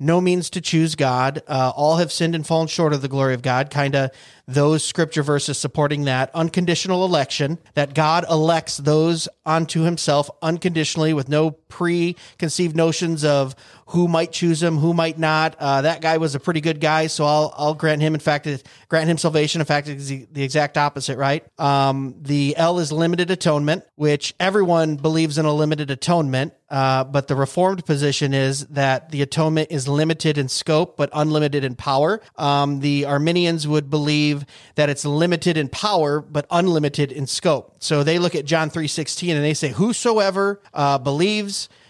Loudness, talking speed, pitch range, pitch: -20 LUFS, 185 wpm, 145-165 Hz, 155 Hz